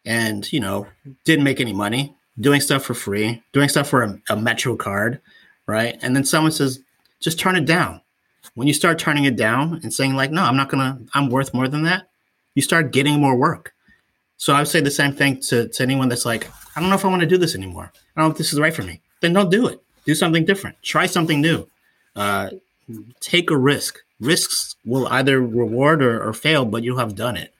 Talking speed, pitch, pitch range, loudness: 235 wpm, 135 Hz, 120-155 Hz, -19 LUFS